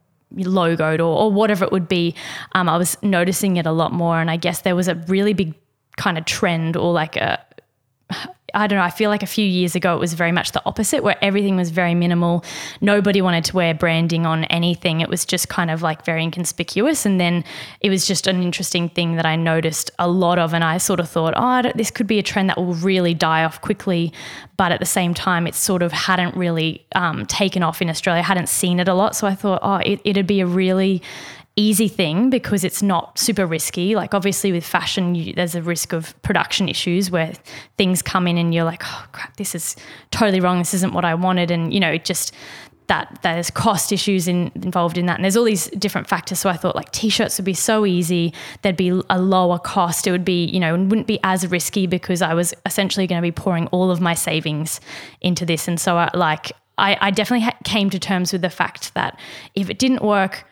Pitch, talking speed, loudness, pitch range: 180 Hz, 235 wpm, -19 LUFS, 170-195 Hz